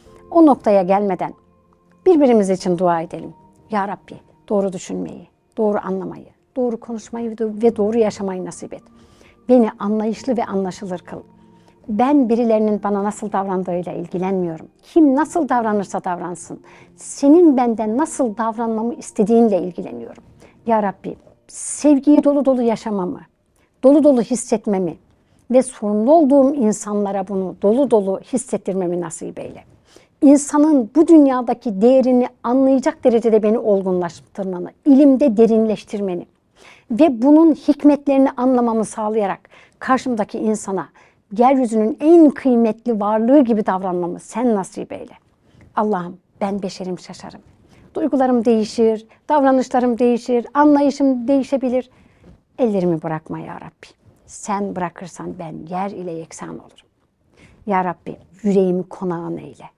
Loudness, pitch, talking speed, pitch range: -17 LUFS, 220 Hz, 110 wpm, 190-255 Hz